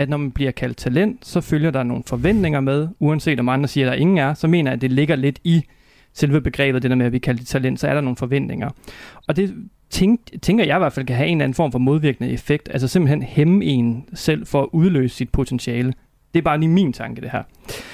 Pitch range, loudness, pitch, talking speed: 130-165 Hz, -19 LUFS, 145 Hz, 260 wpm